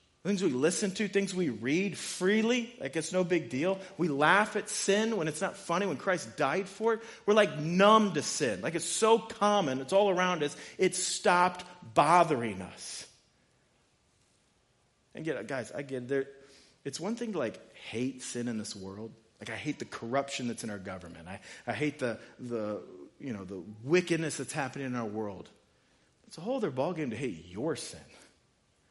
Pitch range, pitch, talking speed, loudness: 125-195 Hz, 165 Hz, 185 wpm, -31 LUFS